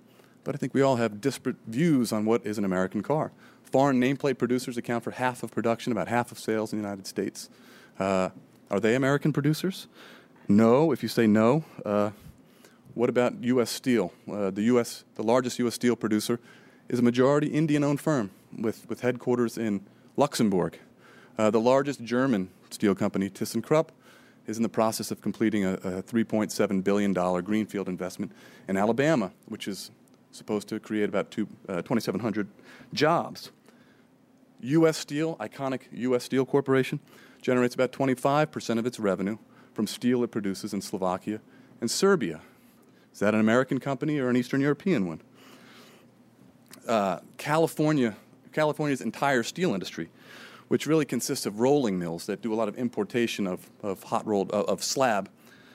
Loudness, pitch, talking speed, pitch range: -27 LUFS, 120 Hz, 160 wpm, 105-135 Hz